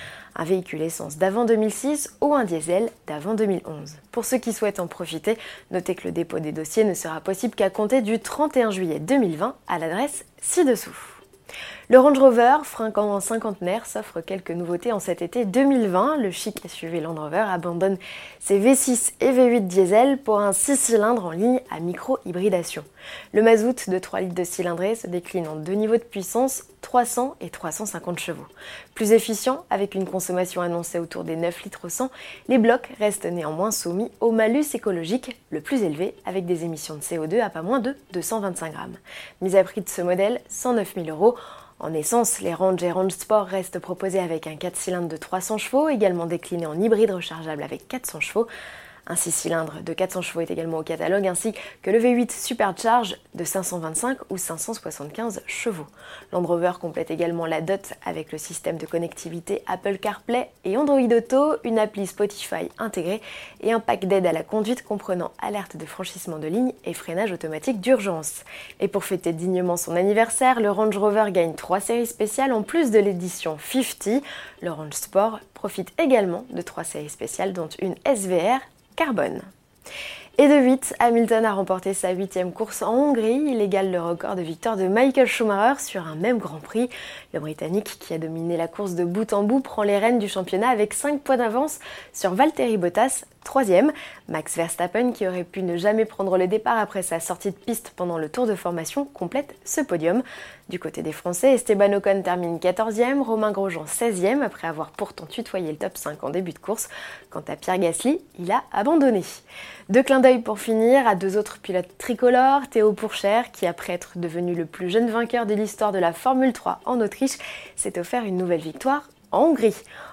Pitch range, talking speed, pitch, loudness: 175-235 Hz, 185 wpm, 200 Hz, -23 LUFS